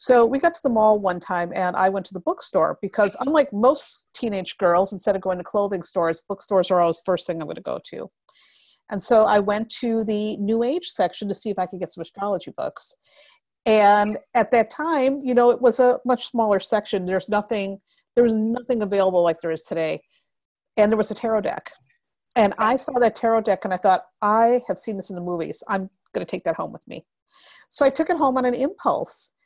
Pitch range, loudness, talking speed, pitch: 190-245 Hz, -22 LUFS, 230 wpm, 210 Hz